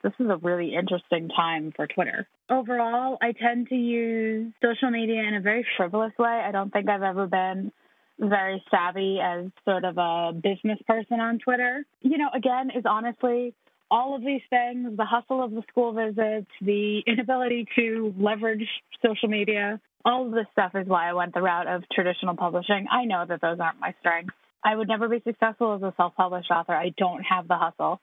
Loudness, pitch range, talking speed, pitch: -26 LUFS, 185-235 Hz, 195 wpm, 215 Hz